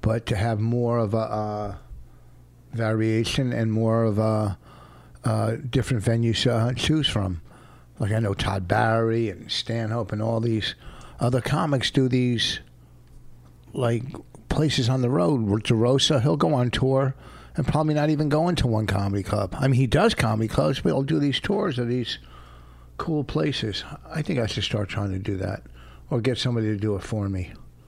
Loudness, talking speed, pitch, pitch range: -24 LUFS, 185 wpm, 115 Hz, 100-130 Hz